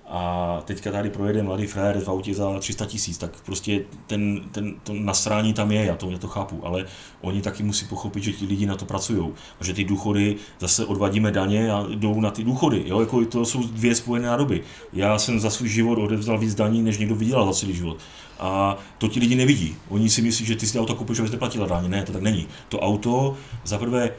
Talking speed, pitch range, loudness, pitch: 225 wpm, 100-115 Hz, -23 LUFS, 105 Hz